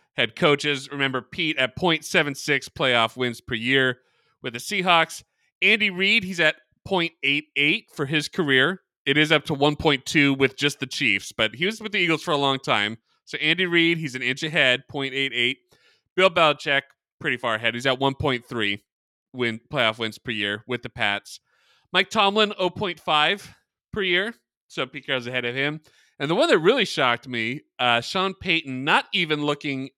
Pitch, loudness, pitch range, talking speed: 145 Hz, -22 LUFS, 125-170 Hz, 175 wpm